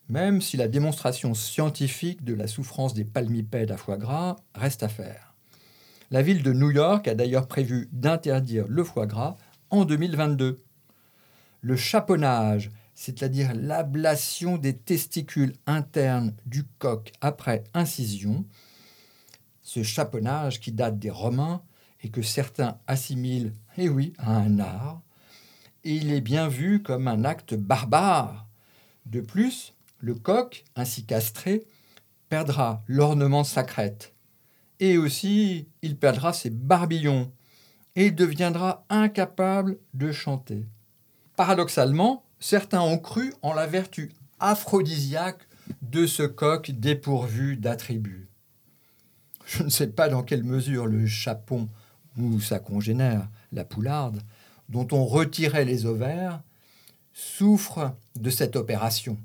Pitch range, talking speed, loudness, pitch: 115-160 Hz, 125 wpm, -26 LUFS, 135 Hz